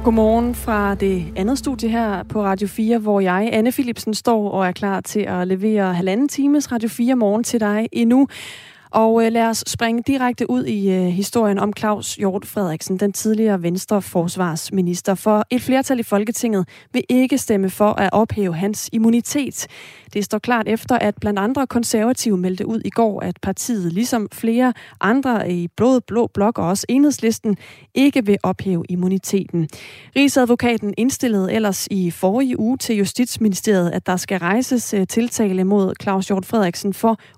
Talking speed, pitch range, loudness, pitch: 165 wpm, 195-235 Hz, -19 LUFS, 215 Hz